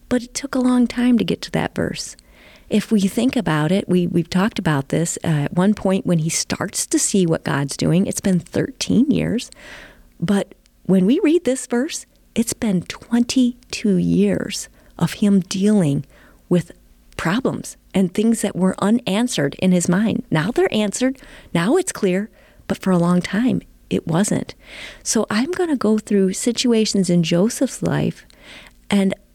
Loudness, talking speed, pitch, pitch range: -19 LUFS, 170 wpm, 205 Hz, 180-245 Hz